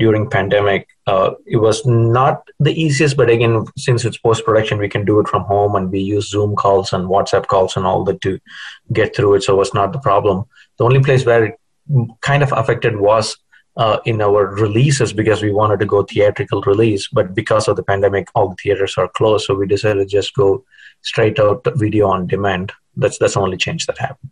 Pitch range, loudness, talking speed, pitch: 100-120 Hz, -15 LUFS, 215 wpm, 105 Hz